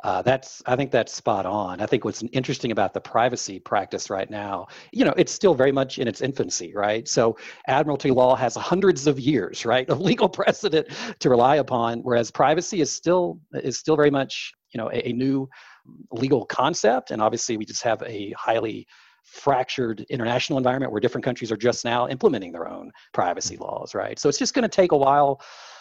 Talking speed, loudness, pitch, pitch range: 200 wpm, -23 LUFS, 130 Hz, 120-150 Hz